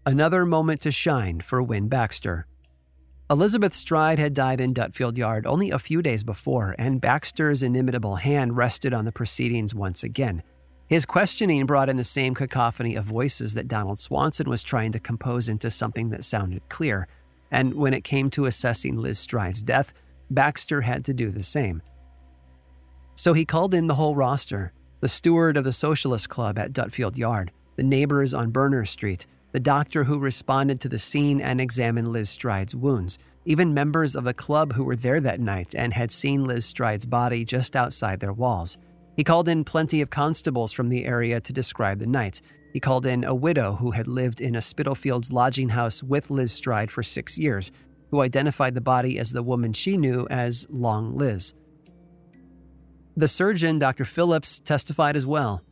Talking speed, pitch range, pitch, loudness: 180 wpm, 110-145 Hz, 125 Hz, -24 LUFS